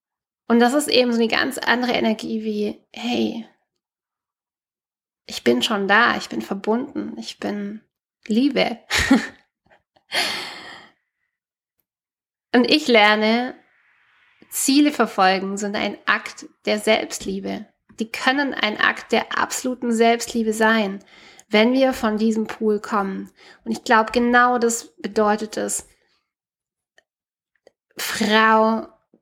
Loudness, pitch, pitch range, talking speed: -20 LUFS, 220 Hz, 210-245 Hz, 110 wpm